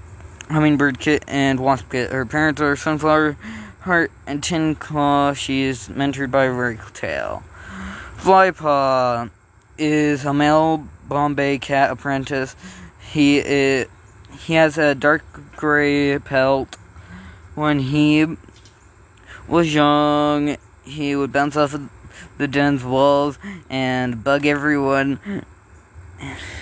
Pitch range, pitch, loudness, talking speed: 115-150 Hz, 140 Hz, -19 LUFS, 110 wpm